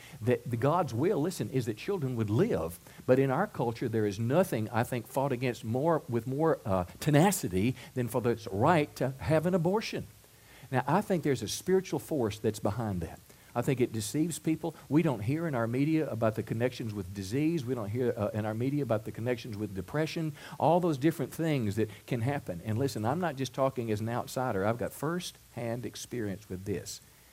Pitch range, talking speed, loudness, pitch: 110-150 Hz, 205 wpm, -31 LUFS, 125 Hz